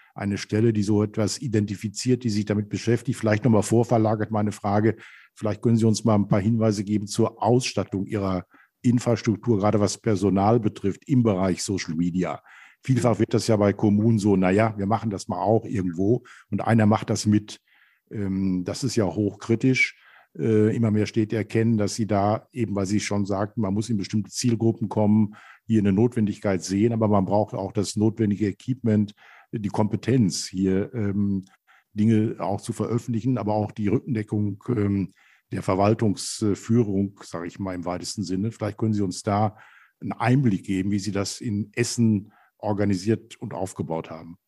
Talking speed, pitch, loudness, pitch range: 170 wpm, 105 Hz, -24 LUFS, 100-115 Hz